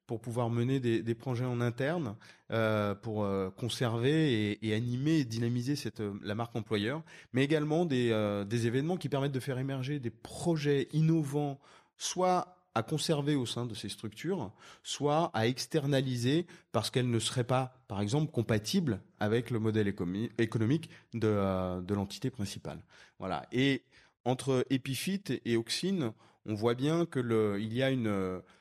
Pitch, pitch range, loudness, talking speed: 125 Hz, 110-145 Hz, -33 LUFS, 160 wpm